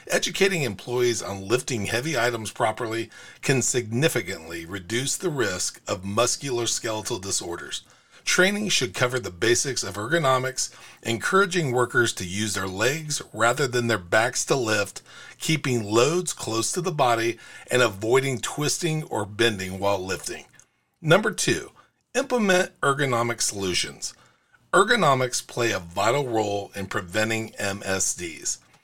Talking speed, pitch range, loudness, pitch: 125 wpm, 105-140 Hz, -24 LUFS, 120 Hz